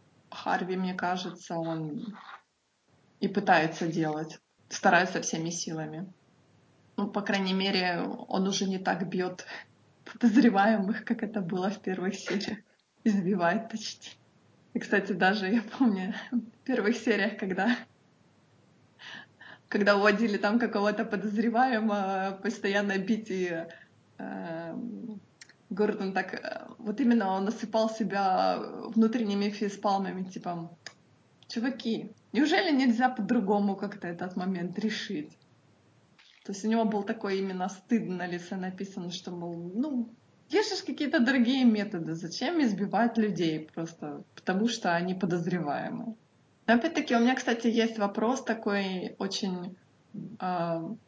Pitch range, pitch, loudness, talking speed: 185-225 Hz, 205 Hz, -29 LUFS, 115 wpm